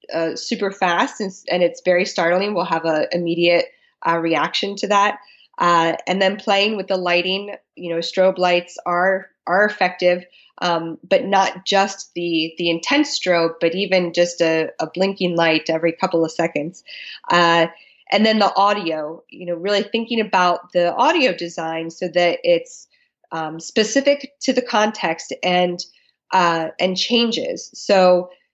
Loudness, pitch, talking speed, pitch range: -19 LUFS, 180 Hz, 160 wpm, 170-205 Hz